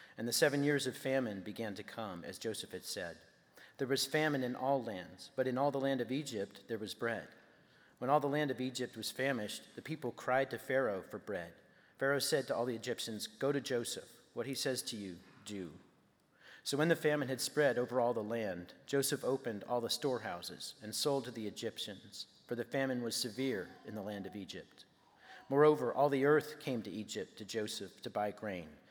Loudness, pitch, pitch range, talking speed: -37 LUFS, 125 Hz, 110-140 Hz, 210 wpm